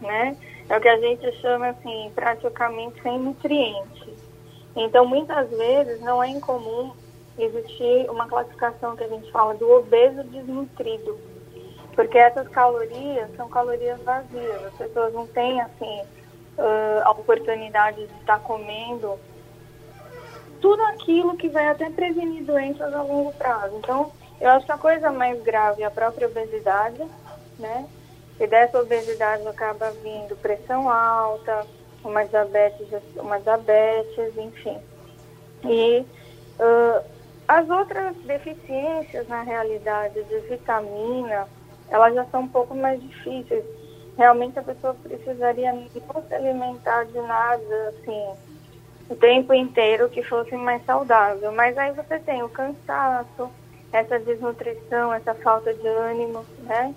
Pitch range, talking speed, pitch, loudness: 215-260 Hz, 130 wpm, 235 Hz, -22 LUFS